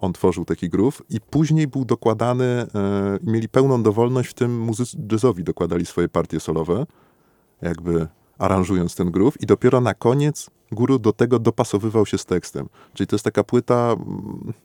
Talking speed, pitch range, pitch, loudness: 170 wpm, 95-125 Hz, 110 Hz, -21 LUFS